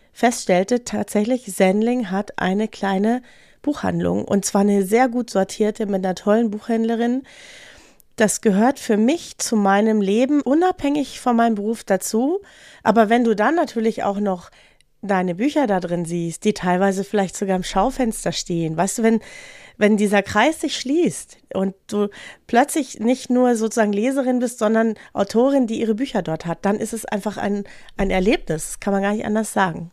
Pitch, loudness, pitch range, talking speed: 215 Hz, -20 LUFS, 195-245 Hz, 170 wpm